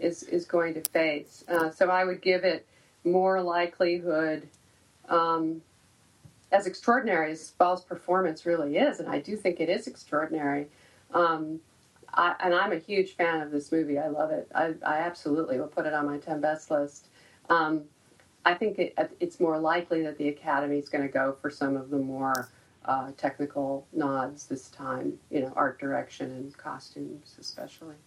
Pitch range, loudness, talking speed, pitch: 145-175 Hz, -28 LUFS, 175 wpm, 160 Hz